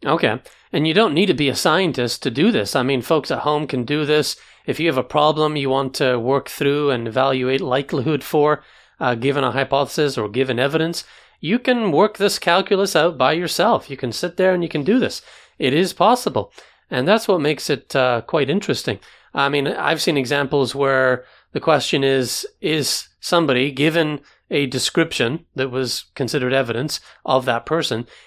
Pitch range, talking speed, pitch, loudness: 130-160 Hz, 190 wpm, 140 Hz, -19 LUFS